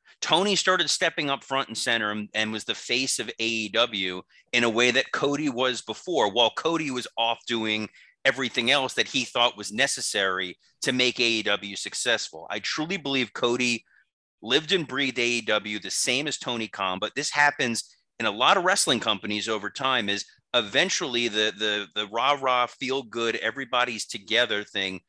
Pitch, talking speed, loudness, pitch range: 120 Hz, 170 wpm, -25 LUFS, 110-135 Hz